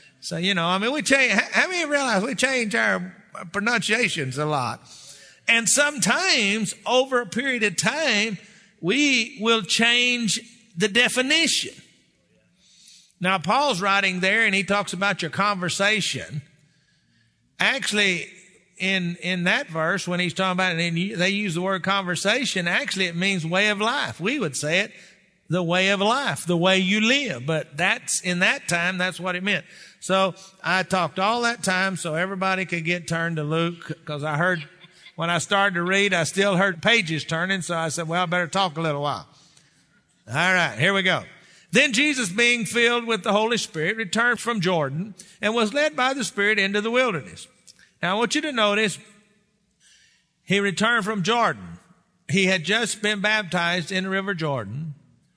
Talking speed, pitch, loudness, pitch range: 175 wpm, 190 Hz, -22 LUFS, 175-220 Hz